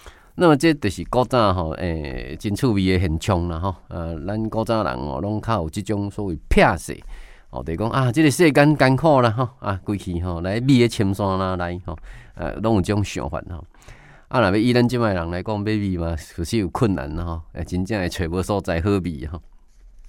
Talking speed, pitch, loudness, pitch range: 310 characters per minute, 100 Hz, -21 LUFS, 85-115 Hz